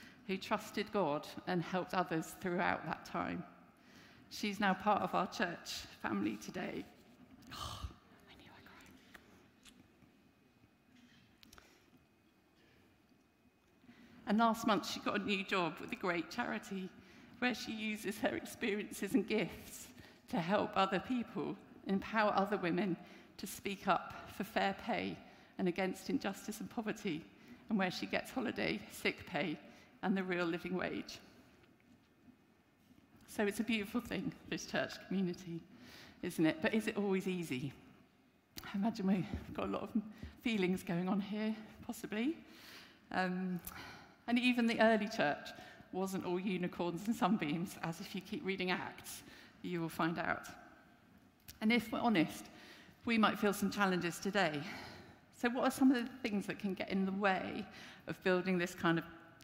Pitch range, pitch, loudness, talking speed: 180-225 Hz, 195 Hz, -38 LUFS, 150 wpm